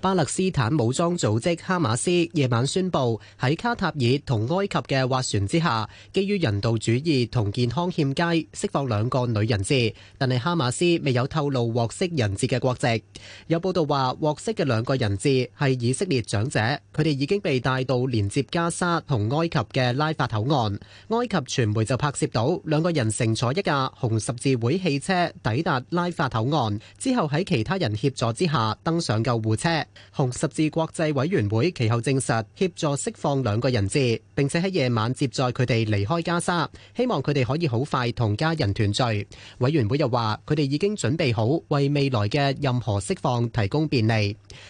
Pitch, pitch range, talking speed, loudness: 135 Hz, 115-160 Hz, 280 characters per minute, -24 LUFS